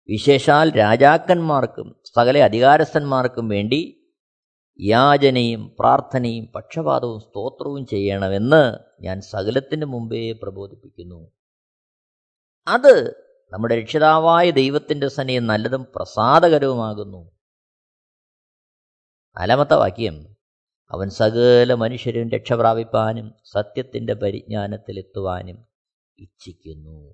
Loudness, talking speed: -18 LUFS, 65 wpm